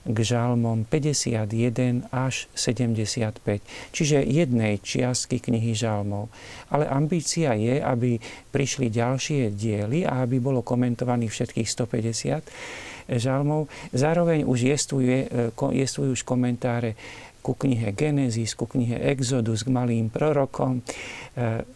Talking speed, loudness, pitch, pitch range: 100 wpm, -25 LUFS, 125 Hz, 115-135 Hz